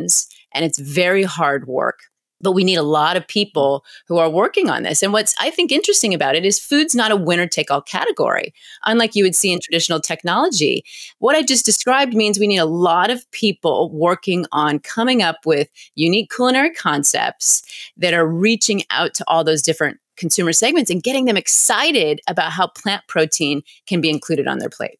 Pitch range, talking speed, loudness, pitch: 160-225 Hz, 195 wpm, -16 LUFS, 185 Hz